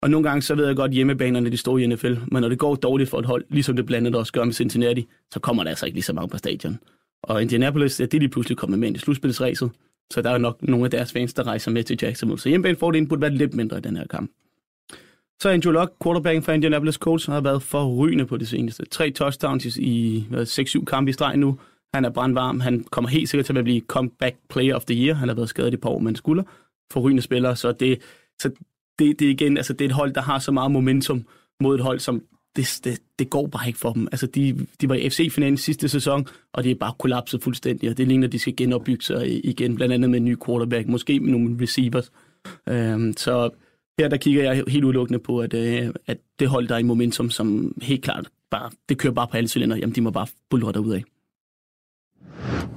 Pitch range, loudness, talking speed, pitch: 120-140 Hz, -22 LUFS, 250 wpm, 125 Hz